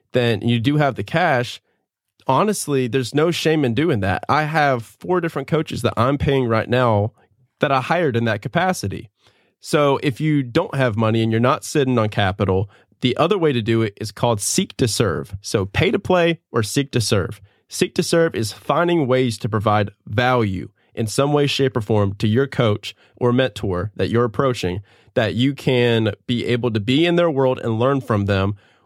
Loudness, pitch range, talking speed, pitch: -19 LUFS, 110-140 Hz, 200 wpm, 125 Hz